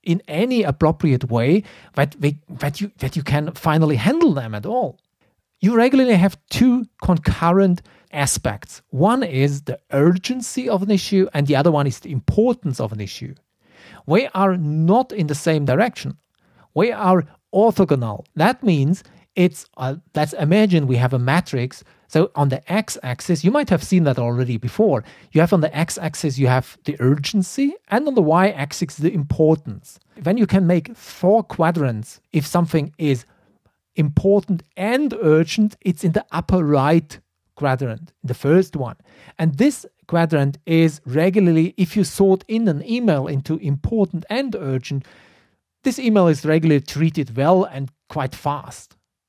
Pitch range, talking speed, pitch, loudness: 140-190 Hz, 160 wpm, 160 Hz, -19 LUFS